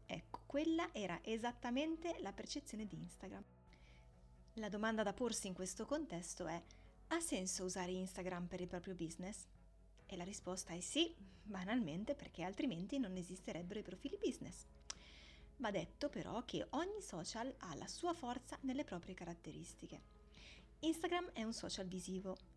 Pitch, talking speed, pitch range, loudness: 195 Hz, 145 wpm, 180-265 Hz, -45 LUFS